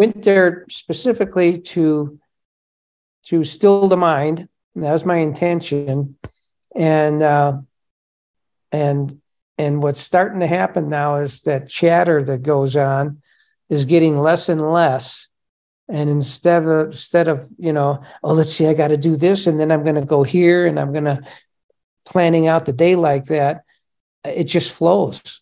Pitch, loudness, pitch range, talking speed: 155 Hz, -17 LUFS, 145-170 Hz, 160 wpm